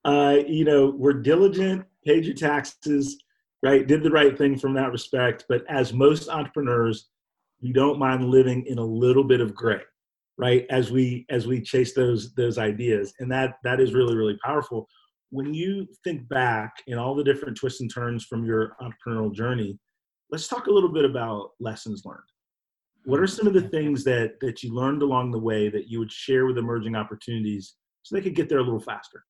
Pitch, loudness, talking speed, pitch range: 130 Hz, -23 LUFS, 200 wpm, 115-145 Hz